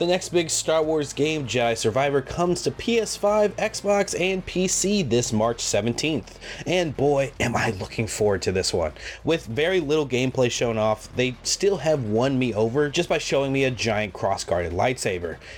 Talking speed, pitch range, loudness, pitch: 180 wpm, 115-175 Hz, -23 LUFS, 140 Hz